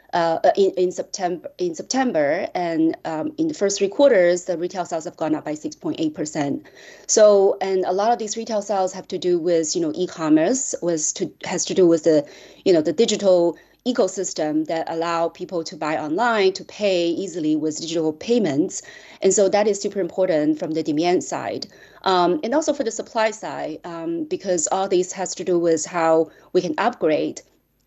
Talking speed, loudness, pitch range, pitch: 200 wpm, -21 LUFS, 170-225 Hz, 185 Hz